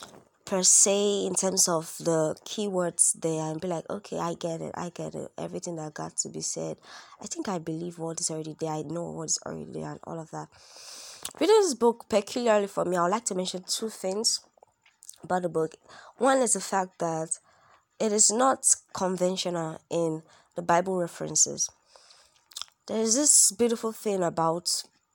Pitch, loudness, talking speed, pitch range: 180 Hz, -26 LUFS, 180 wpm, 165-210 Hz